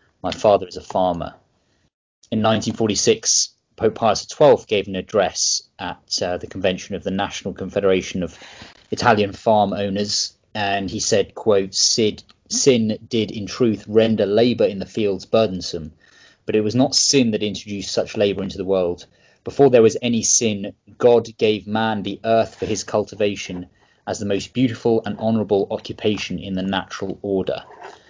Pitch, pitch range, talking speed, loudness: 105 Hz, 95-110 Hz, 160 wpm, -20 LUFS